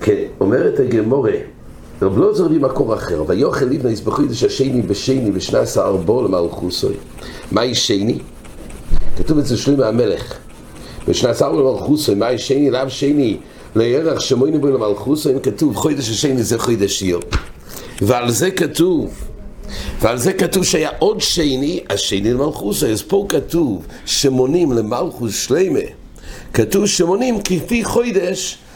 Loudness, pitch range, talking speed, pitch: -17 LUFS, 115-190 Hz, 125 wpm, 140 Hz